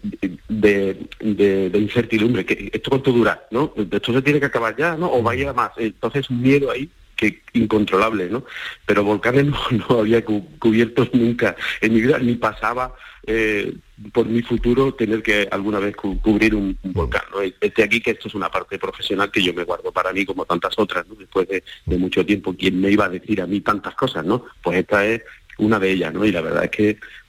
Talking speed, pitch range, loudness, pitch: 210 wpm, 100-120 Hz, -20 LUFS, 110 Hz